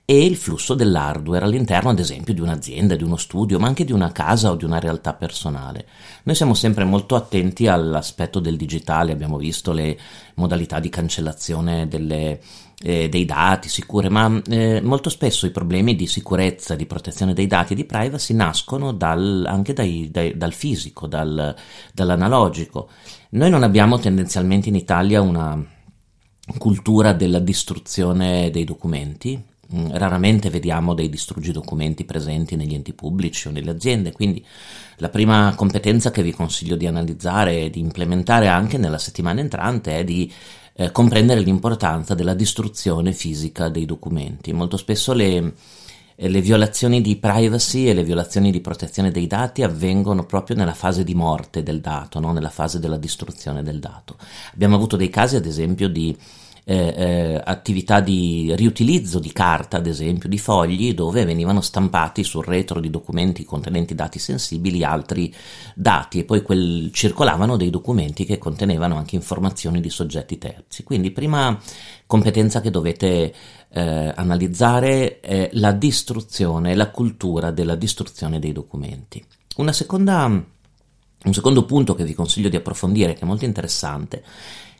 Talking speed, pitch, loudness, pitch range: 155 wpm, 90 Hz, -20 LUFS, 85-105 Hz